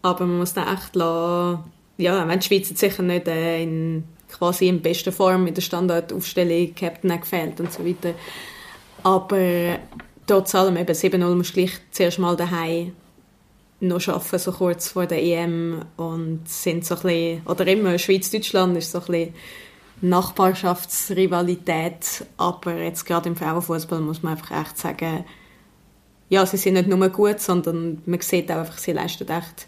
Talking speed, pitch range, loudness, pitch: 160 wpm, 170-185 Hz, -22 LUFS, 175 Hz